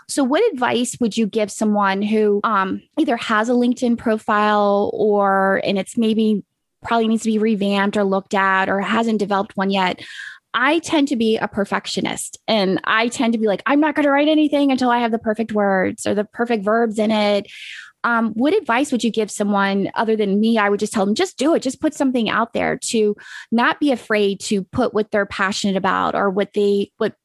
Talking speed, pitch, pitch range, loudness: 215 wpm, 215 Hz, 200-235 Hz, -19 LUFS